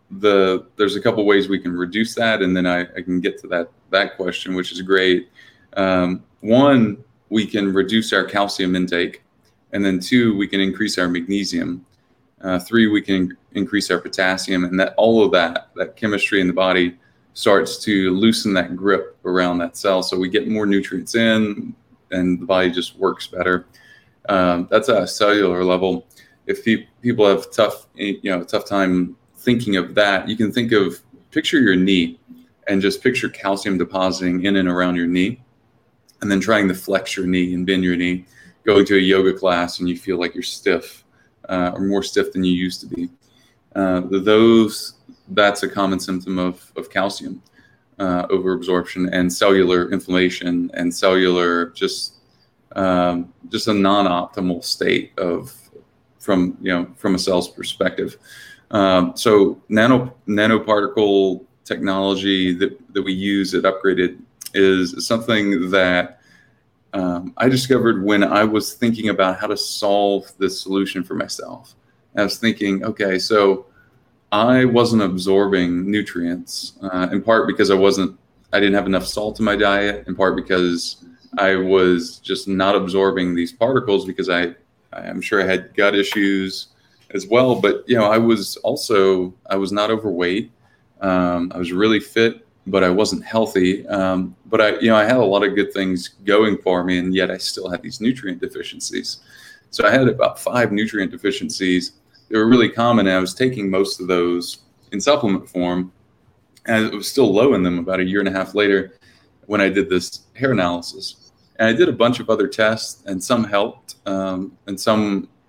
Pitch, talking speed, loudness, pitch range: 95 Hz, 175 wpm, -18 LUFS, 90-105 Hz